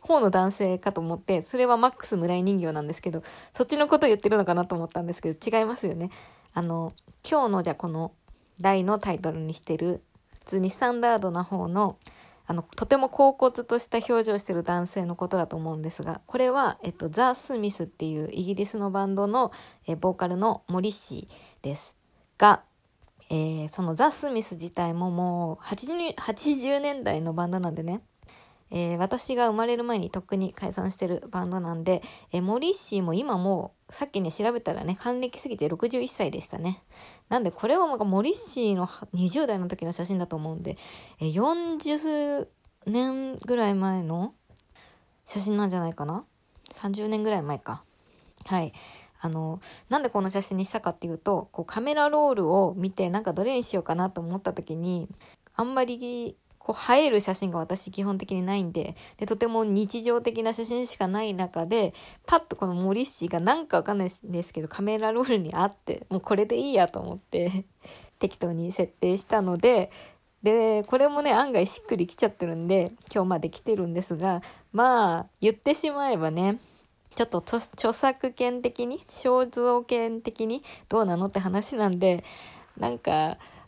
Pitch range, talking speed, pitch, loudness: 175-235 Hz, 350 characters per minute, 195 Hz, -27 LUFS